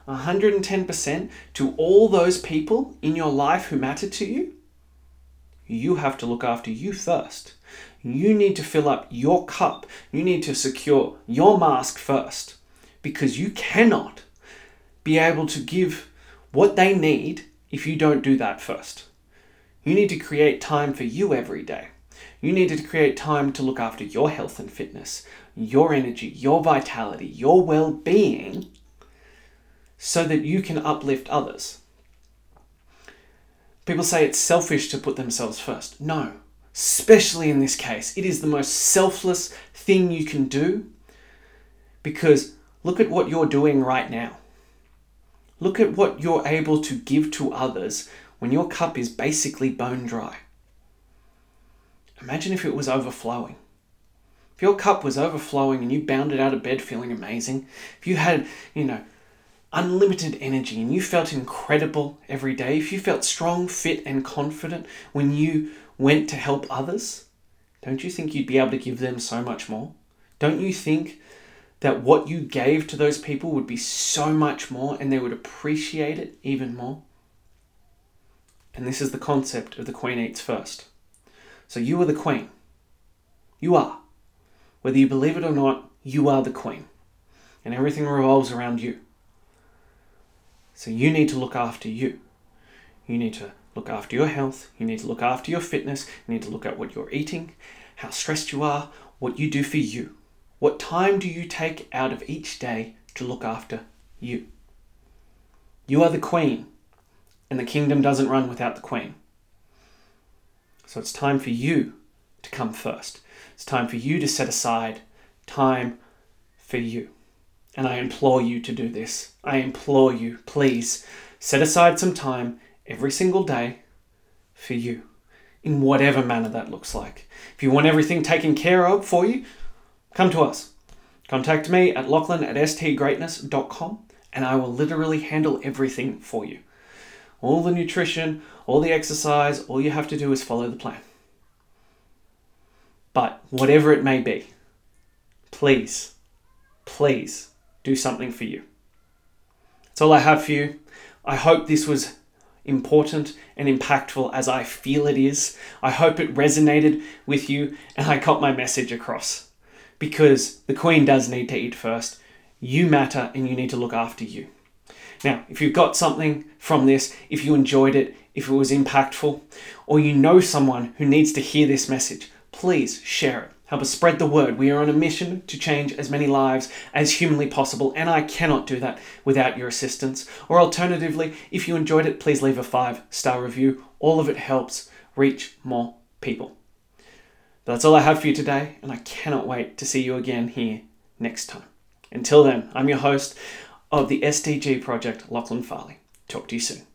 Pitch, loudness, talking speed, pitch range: 140 Hz, -22 LUFS, 170 wpm, 125-155 Hz